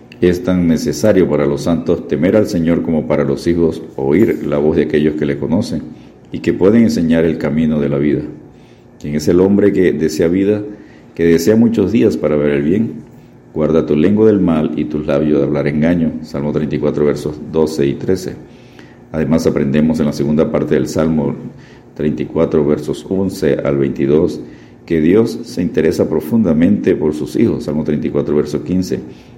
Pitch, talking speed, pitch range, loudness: 75 Hz, 180 wpm, 75-85 Hz, -14 LUFS